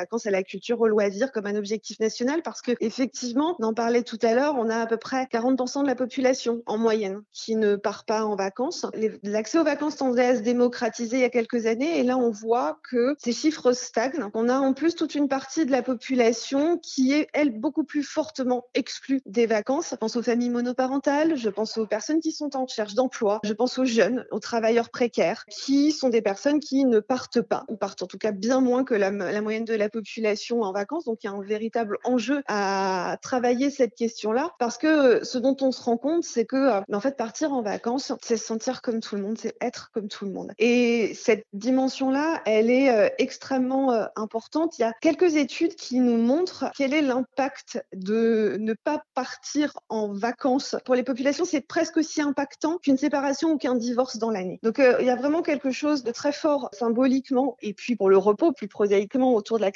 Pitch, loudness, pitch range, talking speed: 245 Hz, -25 LUFS, 225-275 Hz, 225 wpm